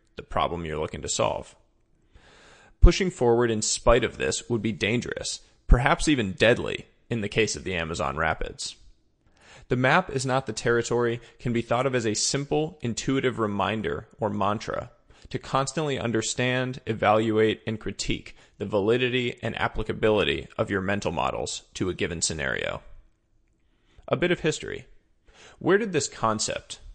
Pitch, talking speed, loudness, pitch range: 120 Hz, 150 wpm, -26 LUFS, 110-130 Hz